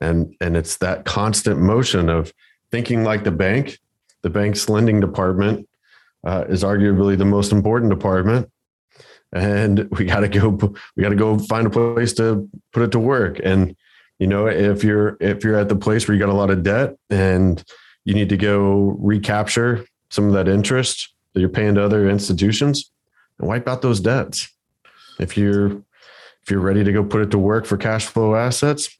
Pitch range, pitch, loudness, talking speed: 100-110 Hz, 105 Hz, -18 LUFS, 190 wpm